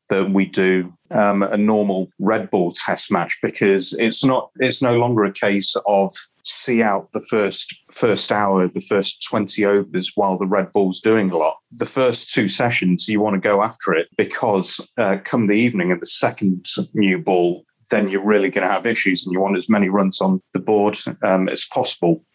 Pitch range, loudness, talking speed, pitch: 95-105 Hz, -18 LUFS, 200 wpm, 100 Hz